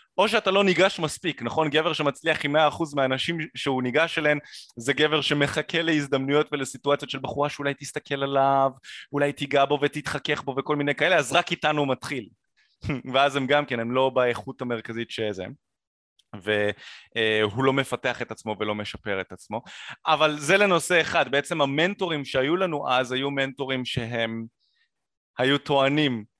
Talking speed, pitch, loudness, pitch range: 155 wpm, 140 Hz, -24 LUFS, 125-150 Hz